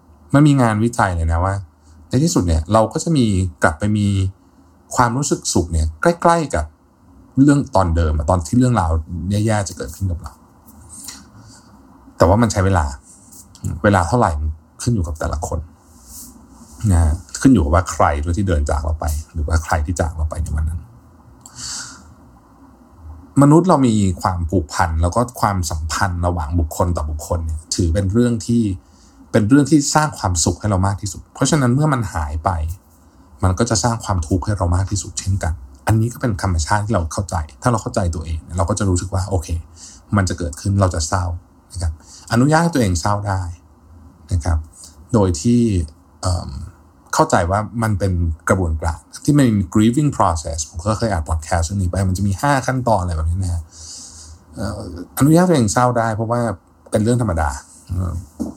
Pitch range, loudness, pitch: 85-110 Hz, -18 LUFS, 95 Hz